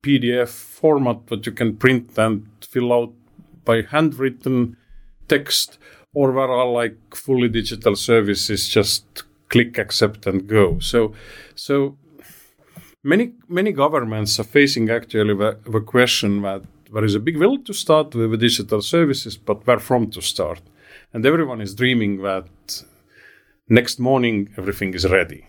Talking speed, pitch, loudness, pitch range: 145 wpm, 115 Hz, -19 LUFS, 105-130 Hz